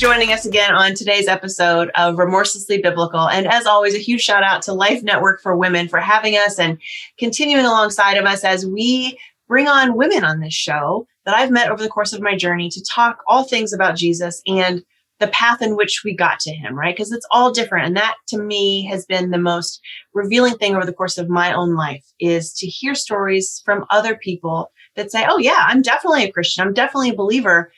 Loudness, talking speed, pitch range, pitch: -16 LUFS, 220 wpm, 175-225 Hz, 200 Hz